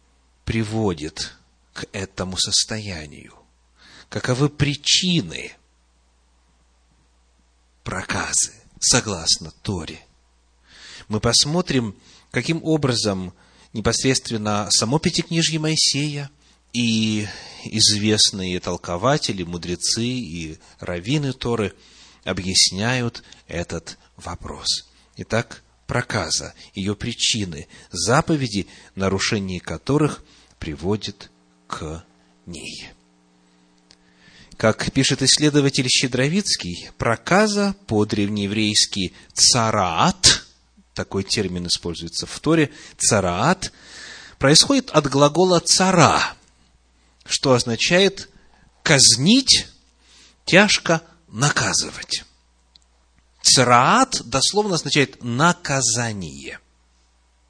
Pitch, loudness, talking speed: 105 Hz, -19 LUFS, 65 wpm